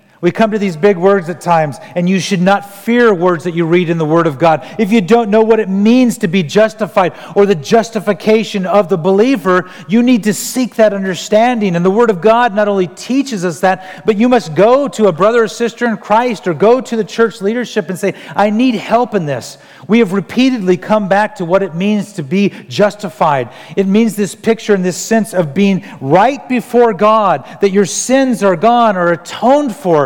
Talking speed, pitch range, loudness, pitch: 220 wpm, 185-225 Hz, -12 LUFS, 205 Hz